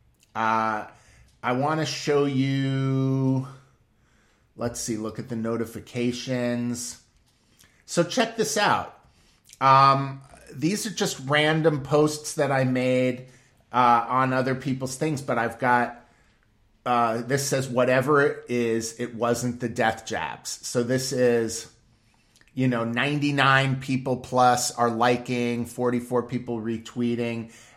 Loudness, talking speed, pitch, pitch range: -24 LUFS, 125 wpm, 125 Hz, 120-135 Hz